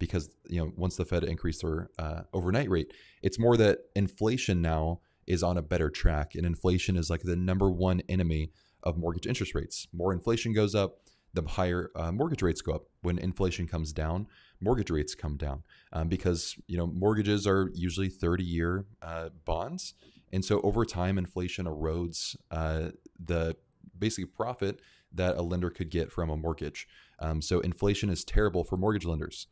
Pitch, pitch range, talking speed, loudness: 90 Hz, 85-95 Hz, 180 wpm, -31 LUFS